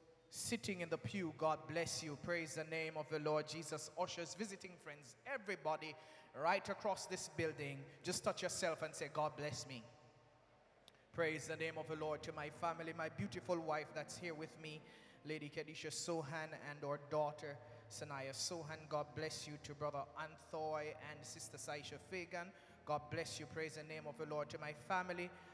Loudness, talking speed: -45 LUFS, 180 wpm